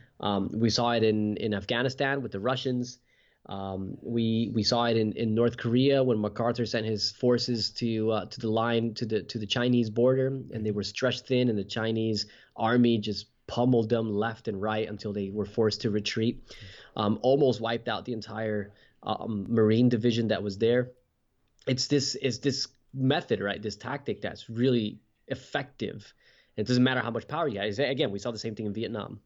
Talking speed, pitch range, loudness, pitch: 195 wpm, 105-125 Hz, -28 LUFS, 115 Hz